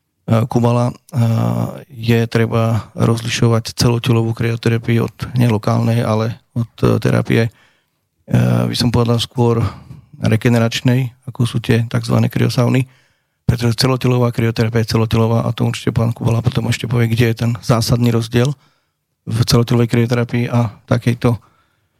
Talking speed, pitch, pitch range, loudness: 120 wpm, 120 Hz, 115-120 Hz, -16 LUFS